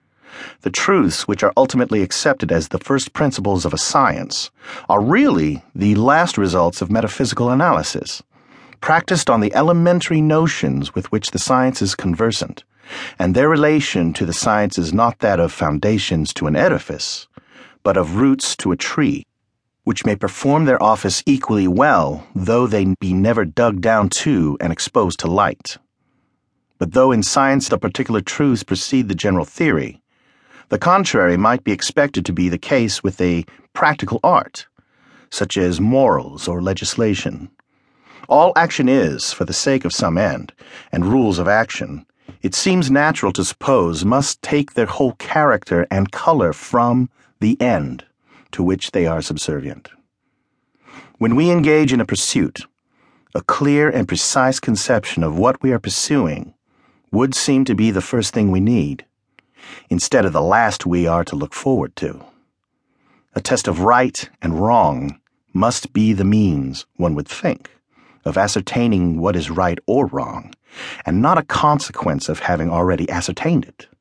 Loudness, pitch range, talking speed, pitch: -17 LUFS, 90-130 Hz, 160 wpm, 105 Hz